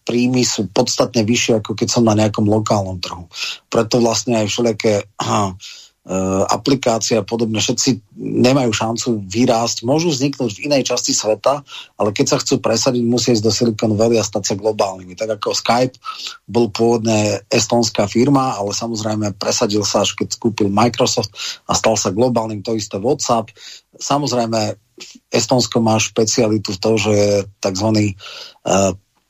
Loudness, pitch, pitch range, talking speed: -17 LUFS, 115 Hz, 105-120 Hz, 155 wpm